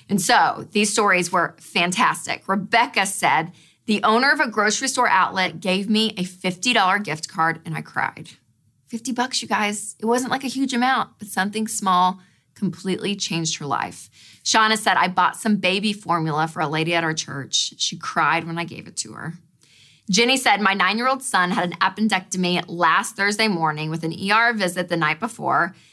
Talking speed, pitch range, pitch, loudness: 185 wpm, 165-215 Hz, 185 Hz, -20 LUFS